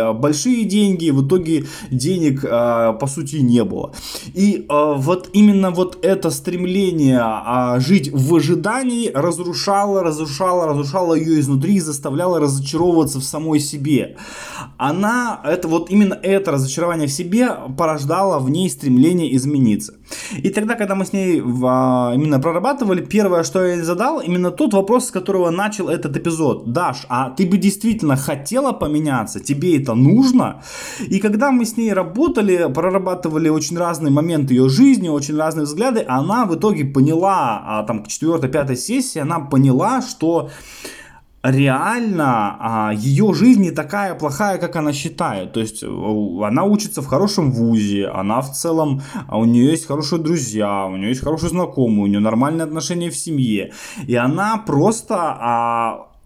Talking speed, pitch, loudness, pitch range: 145 wpm, 160 Hz, -17 LUFS, 135-190 Hz